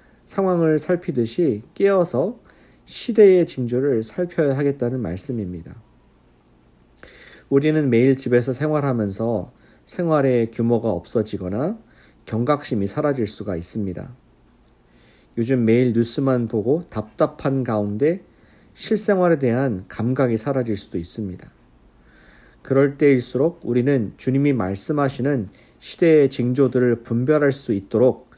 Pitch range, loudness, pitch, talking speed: 110-145 Hz, -20 LUFS, 125 Hz, 275 characters per minute